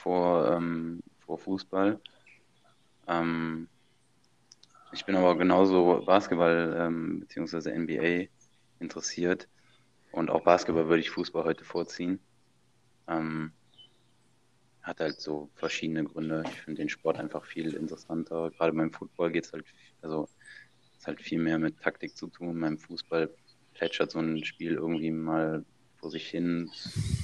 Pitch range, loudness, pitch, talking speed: 80-90 Hz, -30 LUFS, 85 Hz, 135 wpm